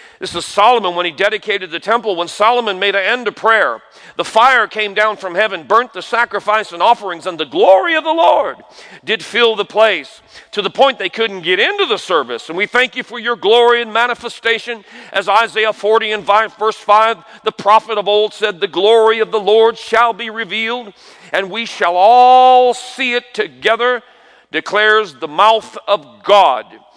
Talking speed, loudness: 190 wpm, -13 LUFS